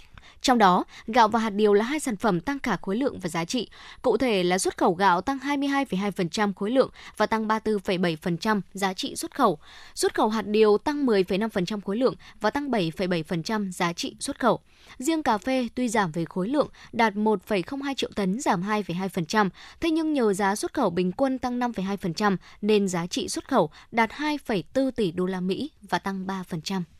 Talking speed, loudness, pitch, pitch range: 195 wpm, -25 LUFS, 215 Hz, 190-255 Hz